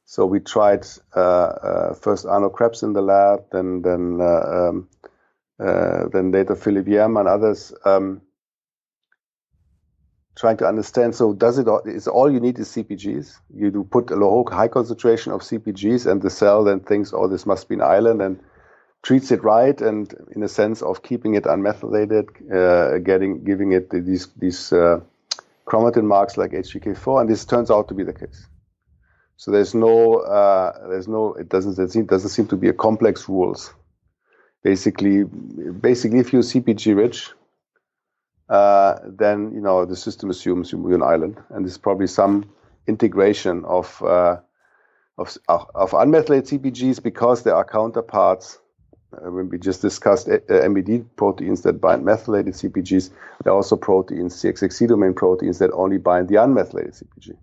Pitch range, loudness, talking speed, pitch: 95-115 Hz, -19 LUFS, 165 wpm, 100 Hz